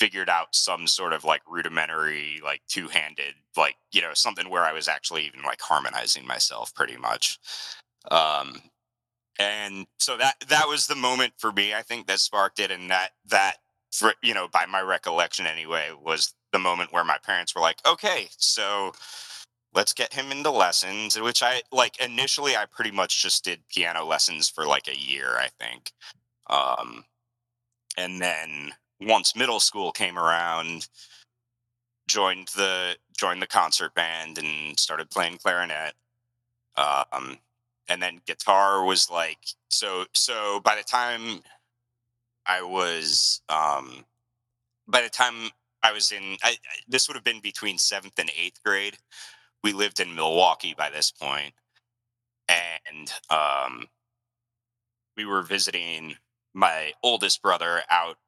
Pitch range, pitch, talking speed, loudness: 90-120 Hz, 110 Hz, 150 wpm, -24 LUFS